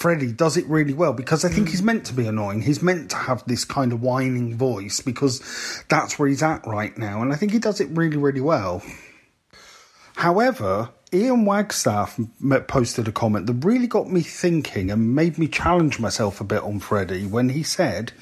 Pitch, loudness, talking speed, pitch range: 135 Hz, -22 LUFS, 200 wpm, 115-165 Hz